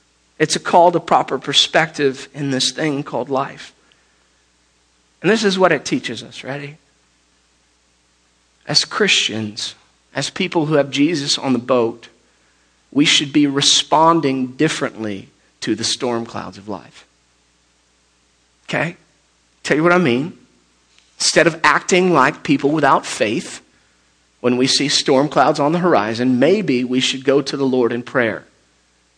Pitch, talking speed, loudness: 125 Hz, 145 wpm, -16 LUFS